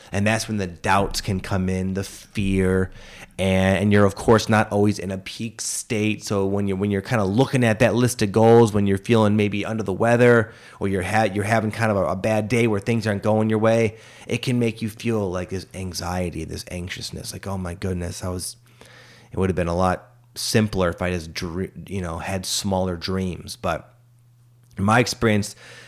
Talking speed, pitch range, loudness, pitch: 220 wpm, 95-115 Hz, -22 LUFS, 105 Hz